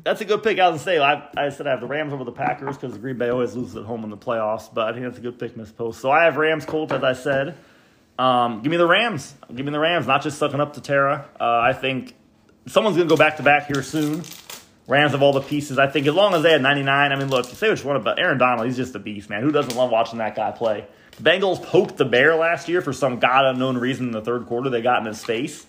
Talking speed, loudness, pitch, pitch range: 305 wpm, -20 LUFS, 135 Hz, 120-150 Hz